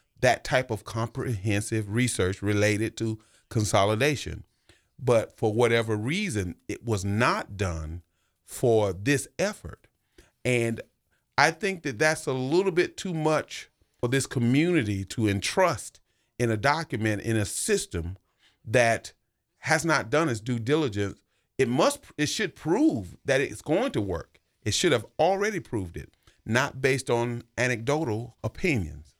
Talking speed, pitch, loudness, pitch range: 140 wpm, 120 Hz, -26 LUFS, 105-145 Hz